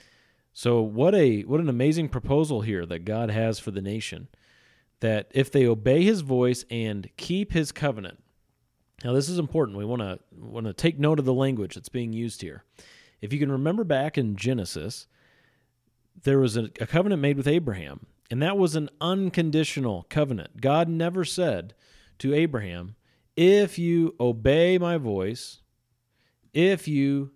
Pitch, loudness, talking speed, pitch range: 130 Hz, -25 LUFS, 165 wpm, 115-155 Hz